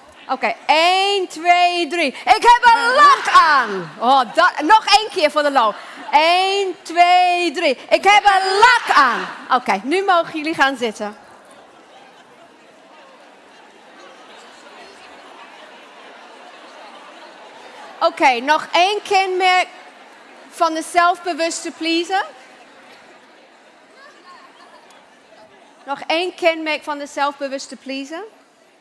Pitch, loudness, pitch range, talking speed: 345 Hz, -15 LUFS, 295-380 Hz, 105 wpm